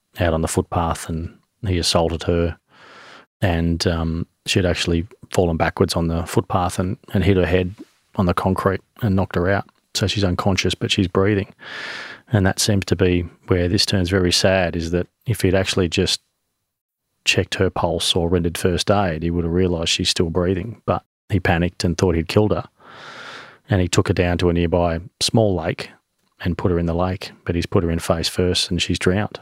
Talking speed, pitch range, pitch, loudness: 200 wpm, 85-100 Hz, 90 Hz, -20 LUFS